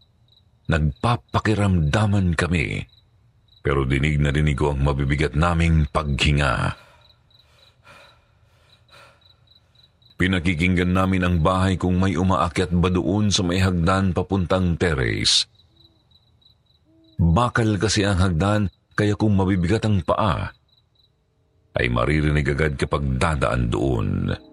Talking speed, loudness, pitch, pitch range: 100 wpm, -21 LUFS, 95 Hz, 80-105 Hz